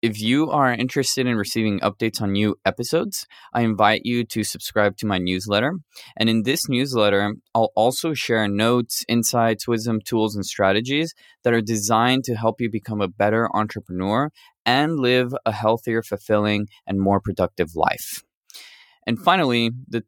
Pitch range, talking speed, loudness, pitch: 105-120 Hz, 160 wpm, -21 LUFS, 115 Hz